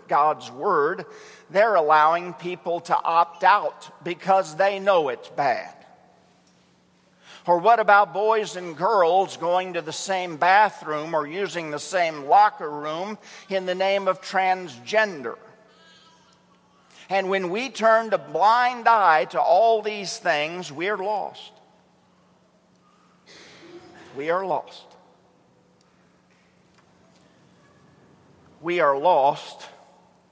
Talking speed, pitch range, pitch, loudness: 110 wpm, 165-210 Hz, 185 Hz, -22 LUFS